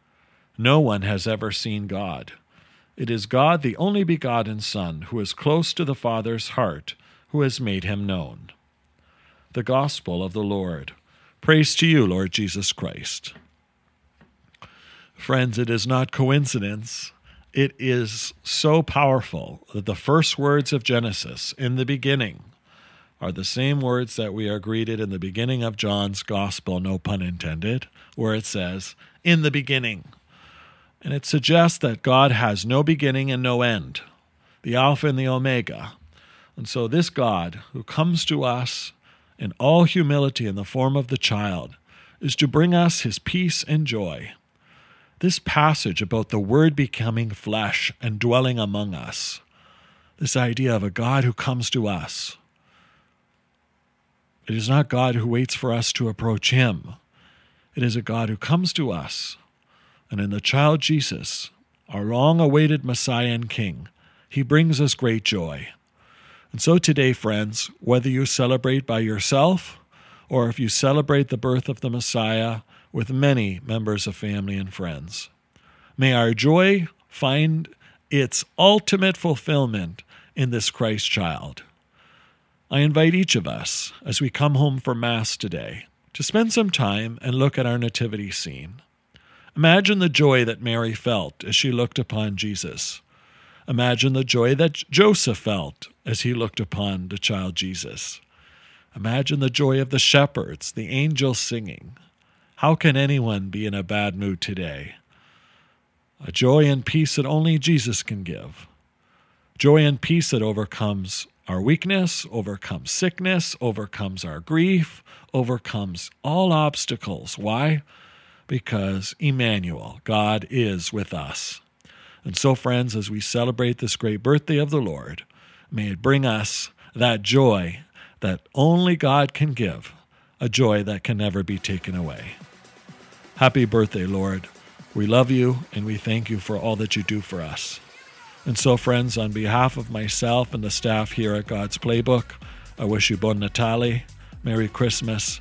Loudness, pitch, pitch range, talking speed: -22 LUFS, 120 Hz, 105-140 Hz, 155 wpm